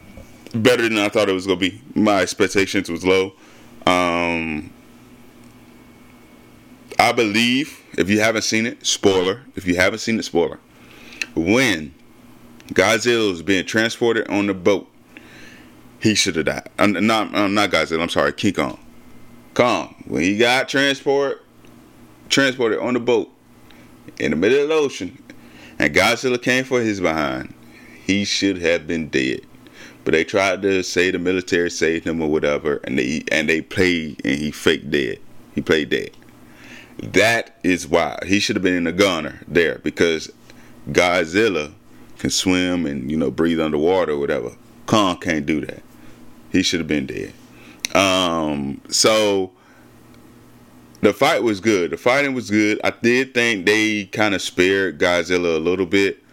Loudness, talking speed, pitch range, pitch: -19 LUFS, 160 wpm, 85-110 Hz, 95 Hz